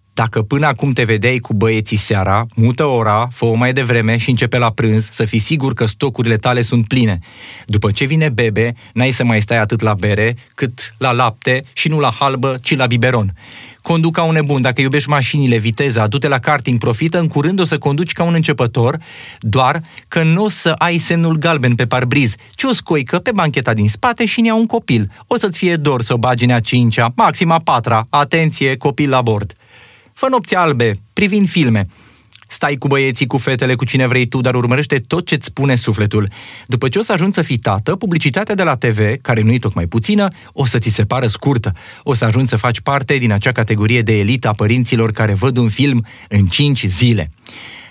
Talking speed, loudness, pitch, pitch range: 210 wpm, -14 LUFS, 125 Hz, 115-150 Hz